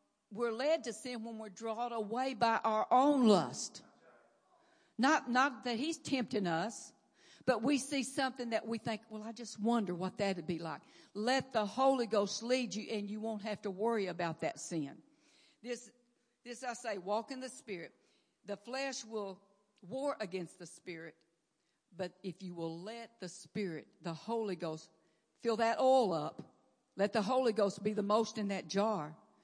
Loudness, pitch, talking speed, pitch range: -36 LUFS, 220 Hz, 180 wpm, 195-245 Hz